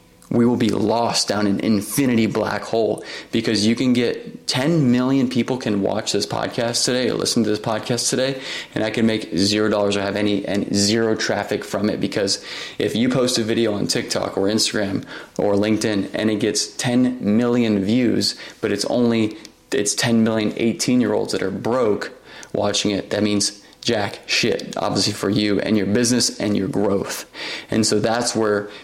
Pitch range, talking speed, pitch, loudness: 105-120 Hz, 185 wpm, 110 Hz, -20 LUFS